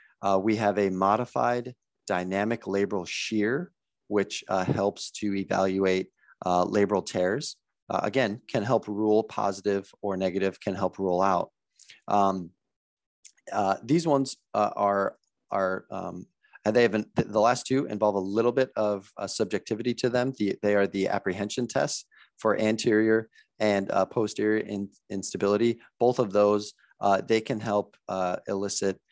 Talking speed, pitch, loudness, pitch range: 155 wpm, 105 Hz, -27 LUFS, 95-110 Hz